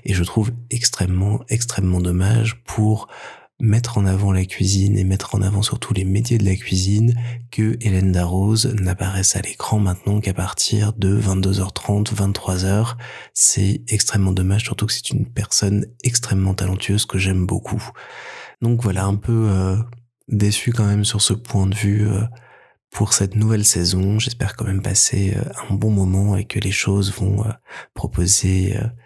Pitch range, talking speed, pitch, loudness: 95-110 Hz, 165 wpm, 105 Hz, -19 LUFS